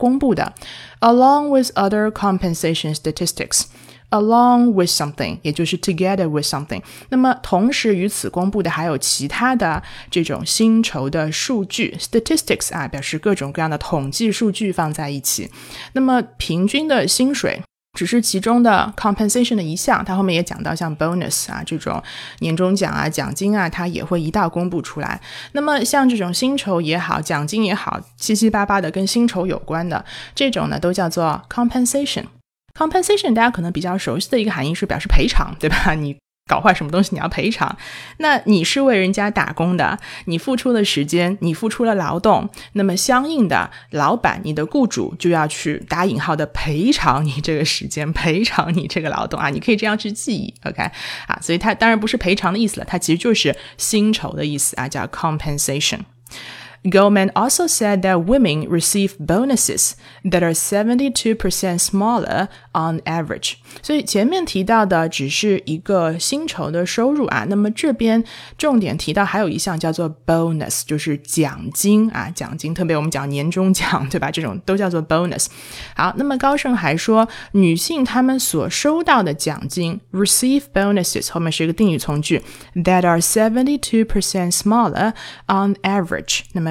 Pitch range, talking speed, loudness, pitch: 165-225 Hz, 410 characters per minute, -18 LUFS, 190 Hz